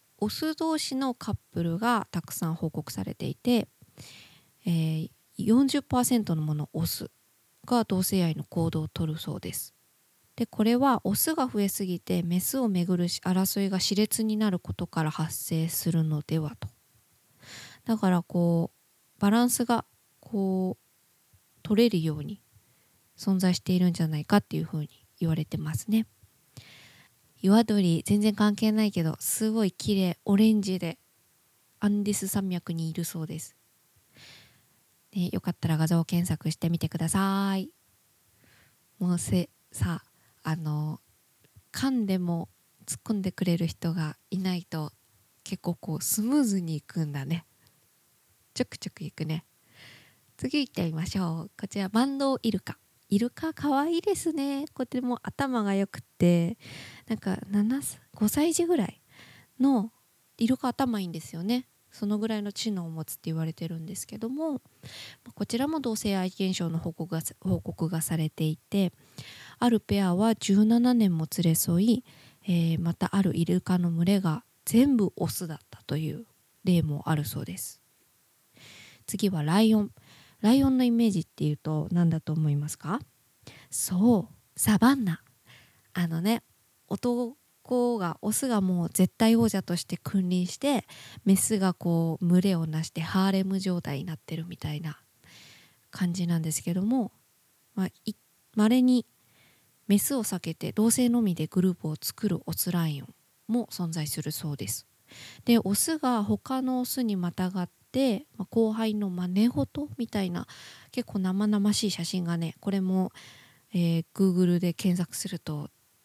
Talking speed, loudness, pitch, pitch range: 285 characters per minute, -28 LUFS, 185 Hz, 160-215 Hz